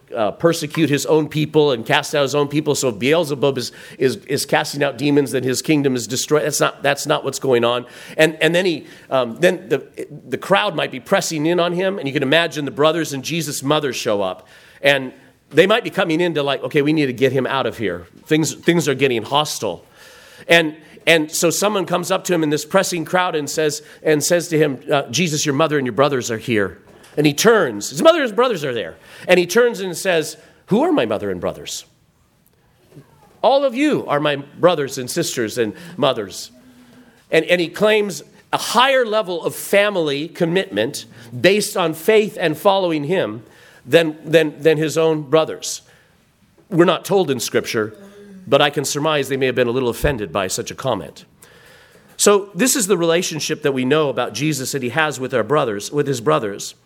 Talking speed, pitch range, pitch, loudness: 210 wpm, 140-175 Hz, 155 Hz, -18 LUFS